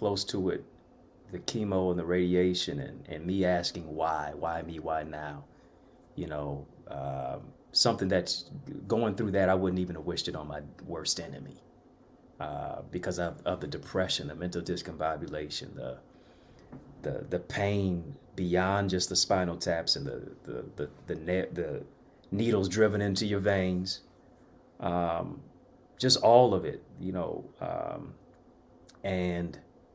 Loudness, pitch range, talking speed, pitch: -31 LUFS, 85-100 Hz, 150 wpm, 90 Hz